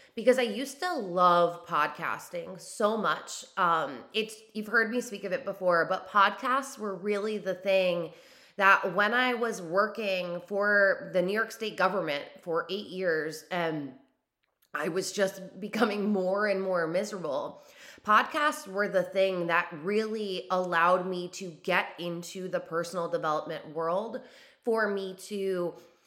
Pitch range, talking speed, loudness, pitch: 175-215 Hz, 150 wpm, -29 LUFS, 190 Hz